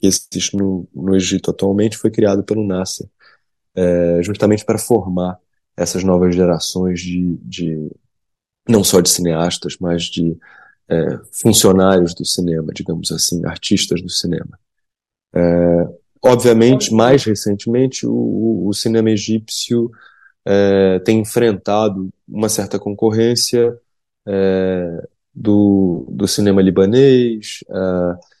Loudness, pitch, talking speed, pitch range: -15 LUFS, 95 Hz, 115 wpm, 90-110 Hz